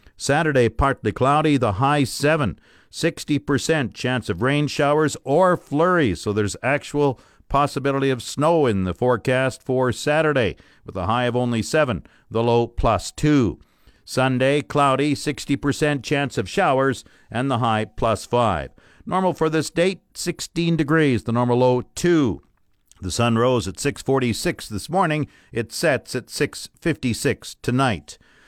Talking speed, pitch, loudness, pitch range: 140 wpm, 130 Hz, -21 LUFS, 115-145 Hz